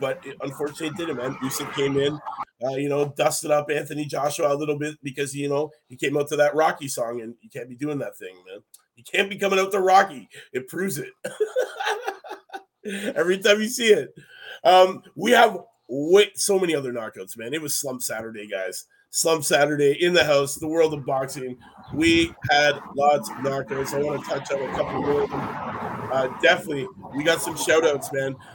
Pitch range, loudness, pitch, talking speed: 140-200 Hz, -23 LUFS, 150 Hz, 200 wpm